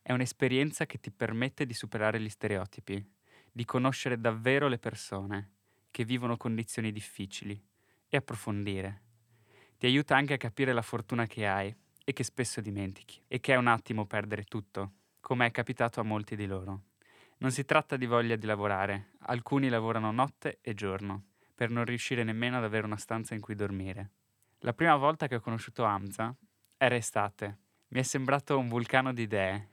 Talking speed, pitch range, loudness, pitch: 175 wpm, 105-125 Hz, -32 LUFS, 115 Hz